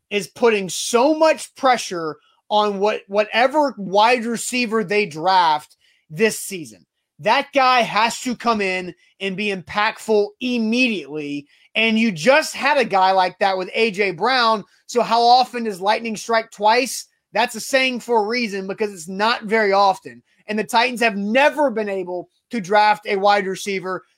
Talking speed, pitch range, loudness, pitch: 160 wpm, 195-235 Hz, -19 LUFS, 215 Hz